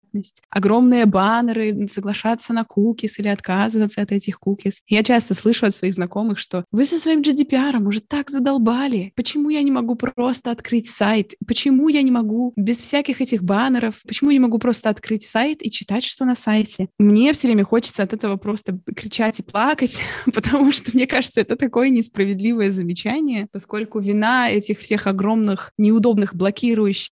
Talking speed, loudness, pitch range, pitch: 170 wpm, -19 LUFS, 205-245 Hz, 220 Hz